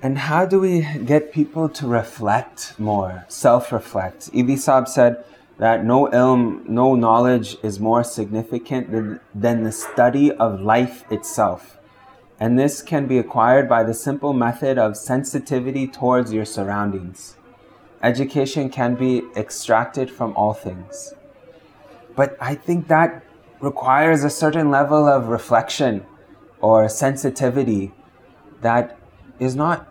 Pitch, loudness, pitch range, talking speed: 125 Hz, -19 LUFS, 110-140 Hz, 125 wpm